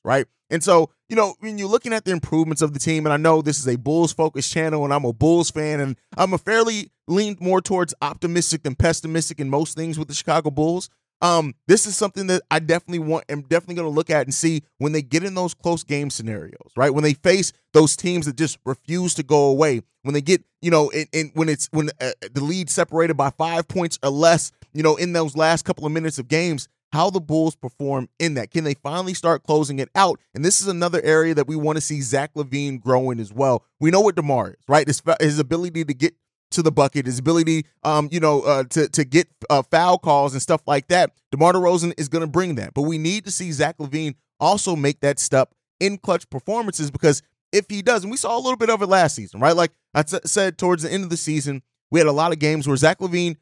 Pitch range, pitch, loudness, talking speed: 145-175 Hz, 160 Hz, -20 LUFS, 250 wpm